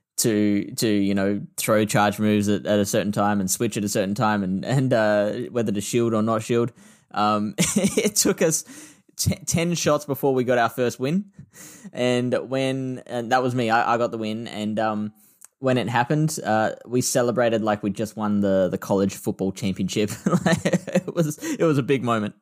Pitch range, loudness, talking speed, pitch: 105-135 Hz, -23 LUFS, 200 wpm, 115 Hz